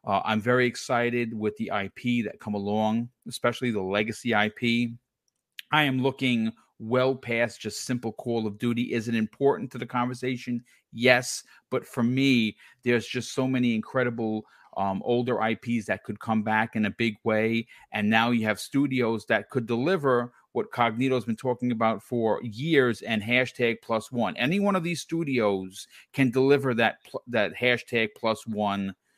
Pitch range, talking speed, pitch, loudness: 110-125 Hz, 170 wpm, 120 Hz, -26 LUFS